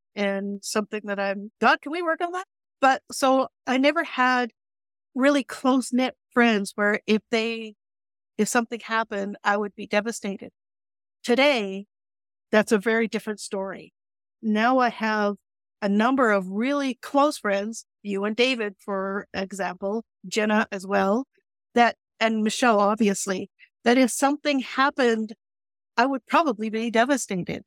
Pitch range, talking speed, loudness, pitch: 205-255 Hz, 140 wpm, -24 LUFS, 225 Hz